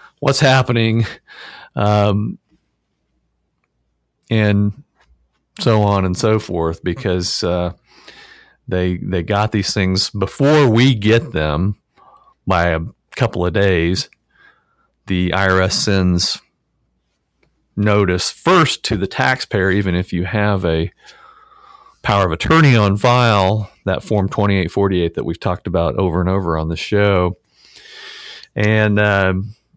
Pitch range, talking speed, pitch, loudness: 90-110 Hz, 120 wpm, 100 Hz, -16 LUFS